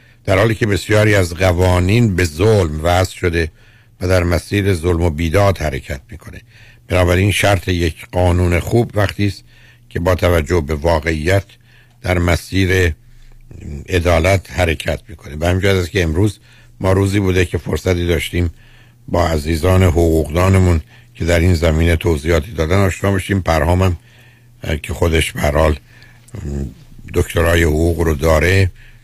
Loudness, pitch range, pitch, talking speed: -16 LUFS, 85-105 Hz, 90 Hz, 135 wpm